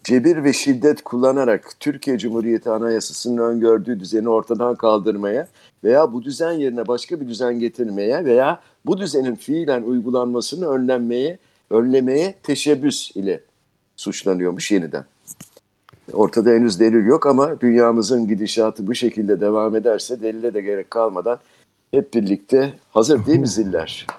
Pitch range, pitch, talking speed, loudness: 110-130 Hz, 120 Hz, 125 wpm, -19 LUFS